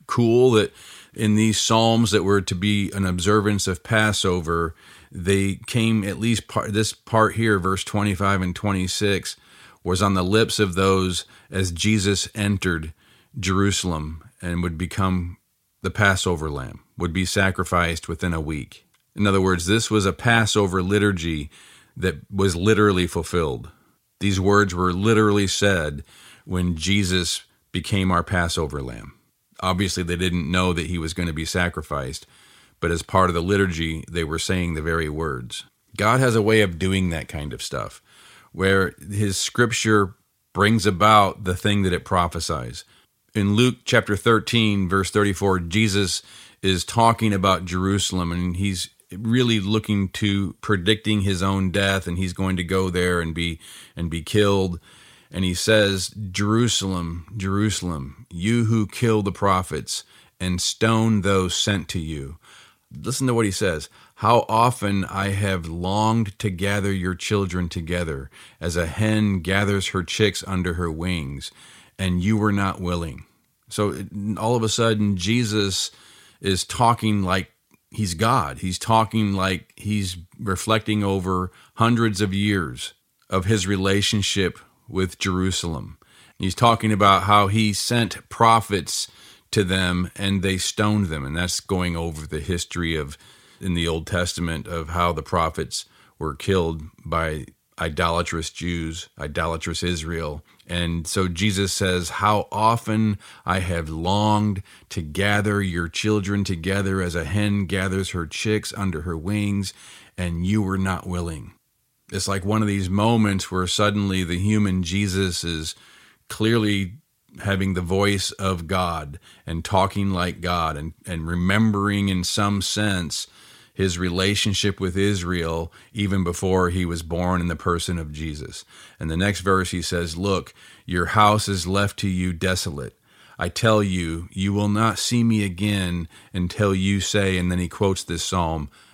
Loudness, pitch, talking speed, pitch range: -22 LUFS, 95 Hz, 150 wpm, 85-105 Hz